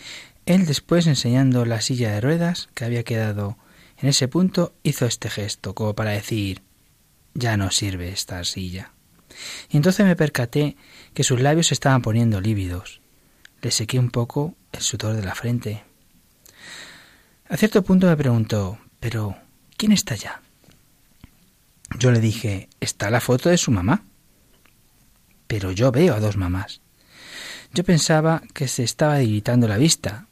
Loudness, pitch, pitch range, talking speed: -21 LUFS, 120 Hz, 105-145 Hz, 150 wpm